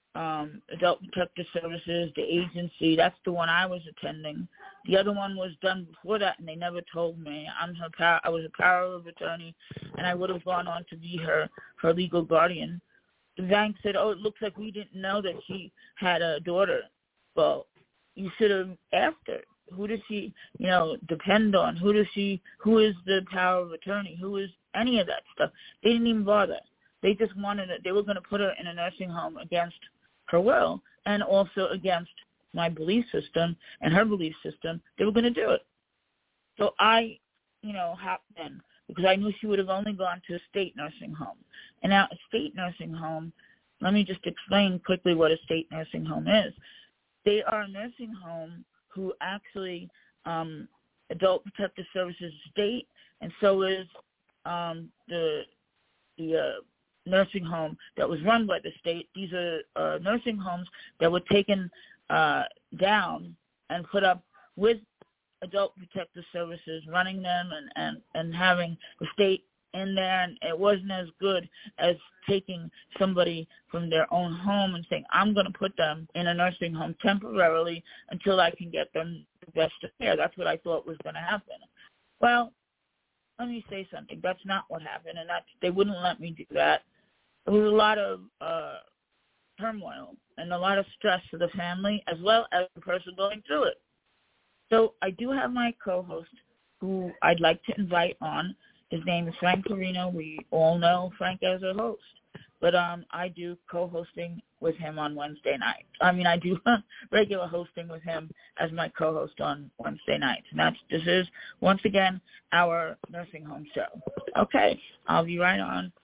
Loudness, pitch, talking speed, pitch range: -28 LUFS, 180 Hz, 185 wpm, 170-200 Hz